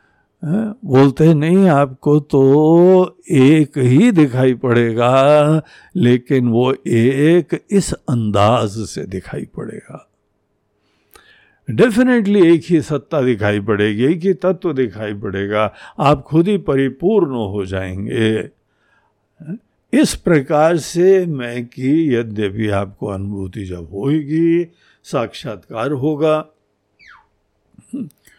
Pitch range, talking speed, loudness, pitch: 110-160 Hz, 95 wpm, -15 LUFS, 135 Hz